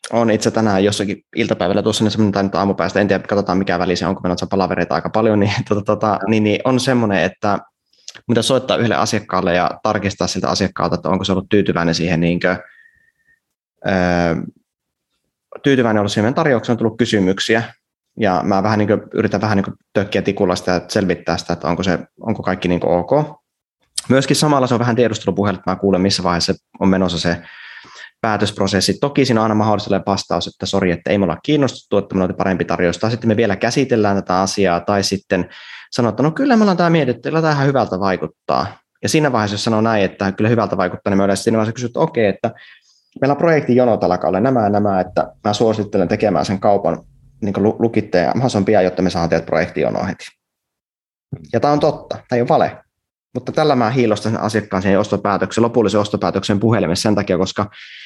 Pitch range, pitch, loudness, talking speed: 95-115 Hz, 105 Hz, -17 LUFS, 195 wpm